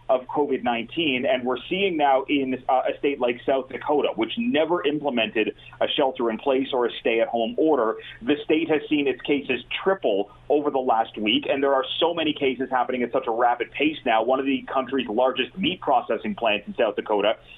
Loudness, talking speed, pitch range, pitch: -23 LUFS, 210 wpm, 120-150 Hz, 135 Hz